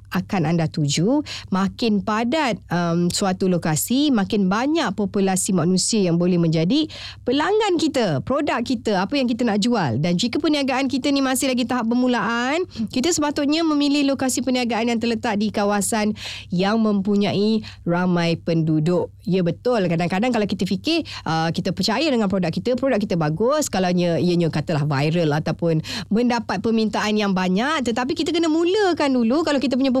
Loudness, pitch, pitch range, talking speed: -20 LUFS, 215 Hz, 180-260 Hz, 155 wpm